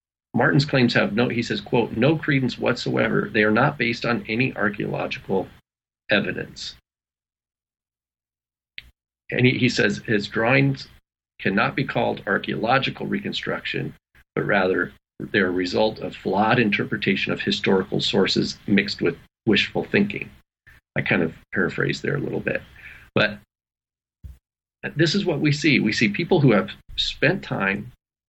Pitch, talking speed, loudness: 105 Hz, 140 wpm, -22 LUFS